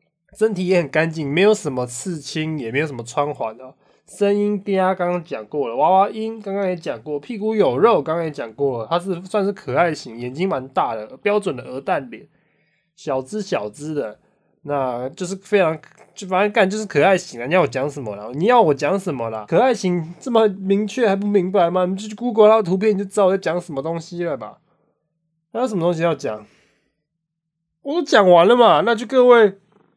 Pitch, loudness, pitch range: 175 Hz, -19 LUFS, 150-205 Hz